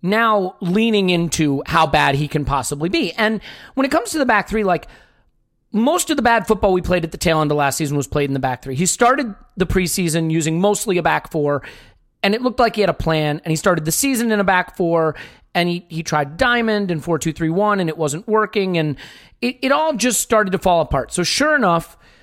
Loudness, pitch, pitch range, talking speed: -18 LUFS, 180 Hz, 160-220 Hz, 245 wpm